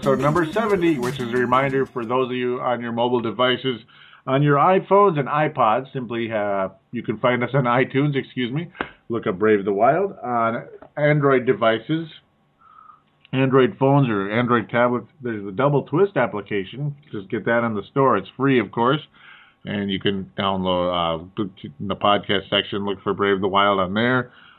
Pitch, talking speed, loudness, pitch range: 125 Hz, 180 wpm, -21 LUFS, 105-135 Hz